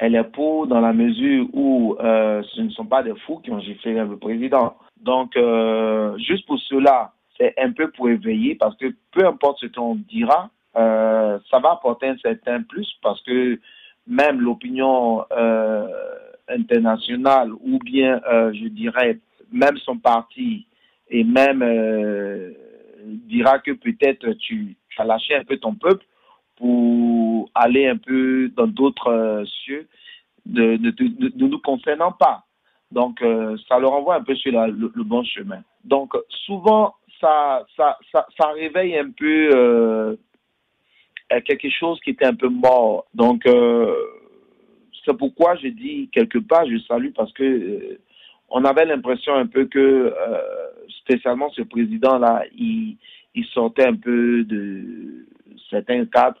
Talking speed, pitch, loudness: 155 wpm, 135 Hz, -19 LUFS